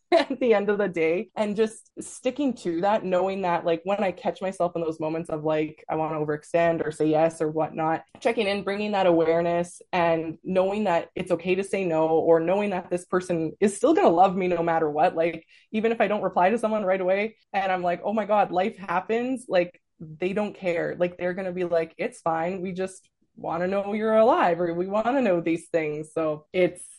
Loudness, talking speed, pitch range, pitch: -25 LUFS, 235 wpm, 165-200 Hz, 180 Hz